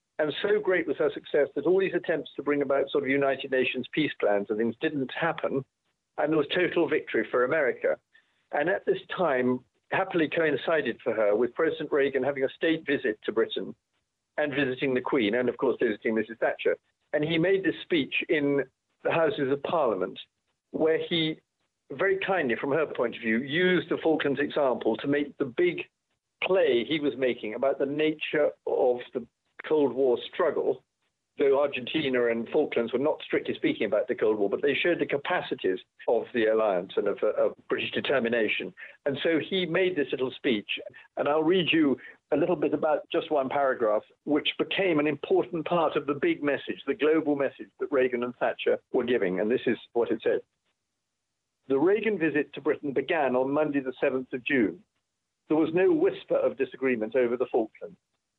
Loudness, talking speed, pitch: -27 LUFS, 190 wpm, 160 Hz